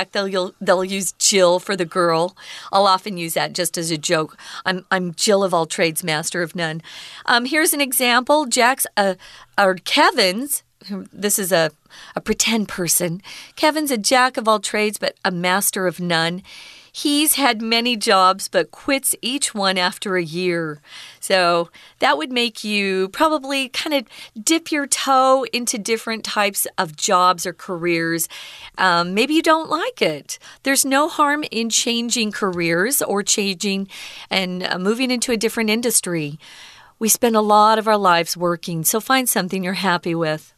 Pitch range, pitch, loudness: 180-245 Hz, 200 Hz, -18 LUFS